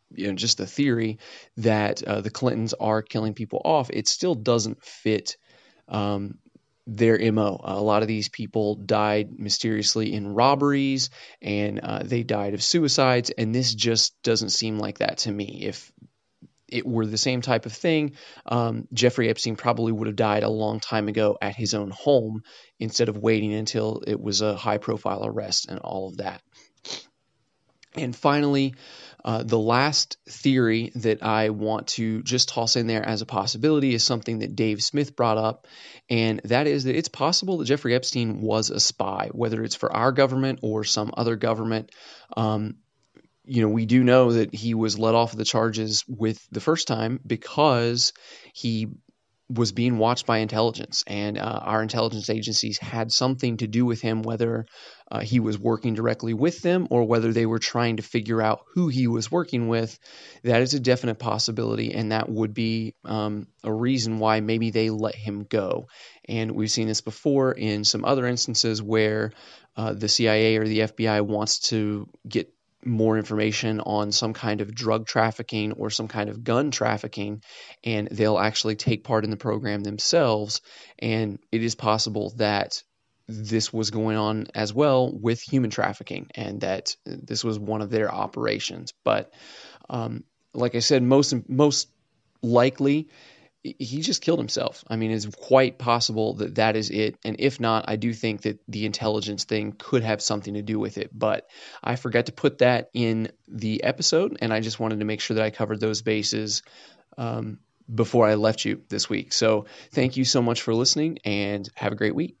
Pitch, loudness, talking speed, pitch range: 110 Hz, -24 LUFS, 180 wpm, 110-120 Hz